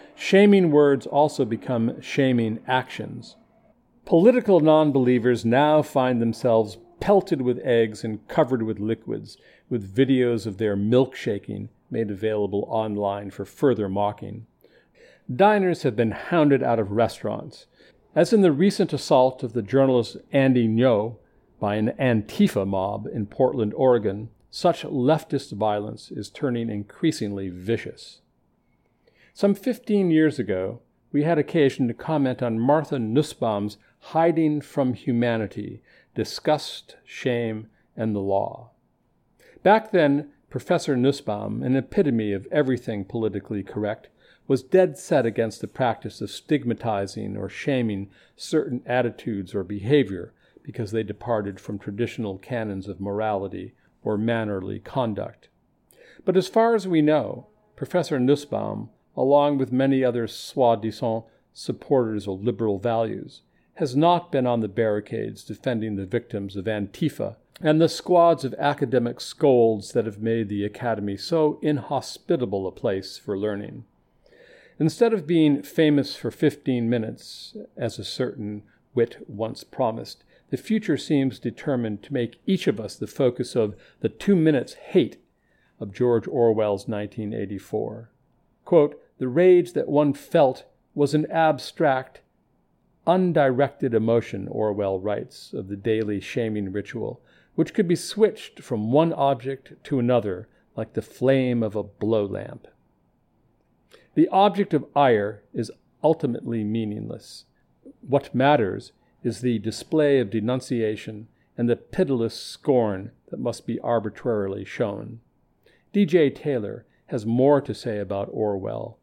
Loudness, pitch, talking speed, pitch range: -23 LUFS, 120 Hz, 130 wpm, 110-145 Hz